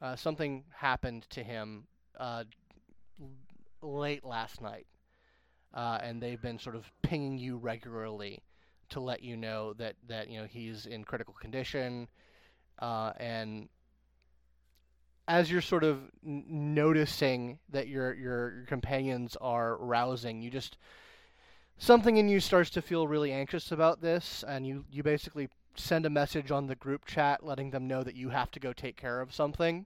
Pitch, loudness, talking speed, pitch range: 130 Hz, -33 LUFS, 160 wpm, 115-150 Hz